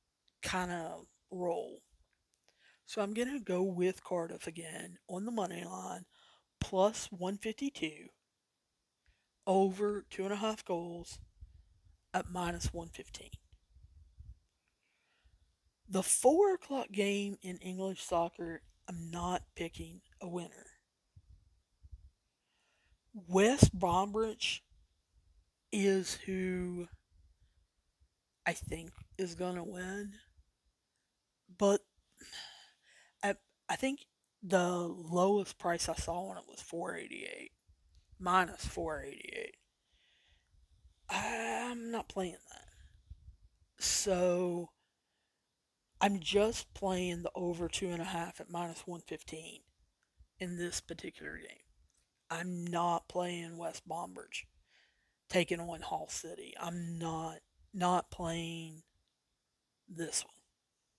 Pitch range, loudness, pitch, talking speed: 160-195 Hz, -36 LUFS, 175 Hz, 95 wpm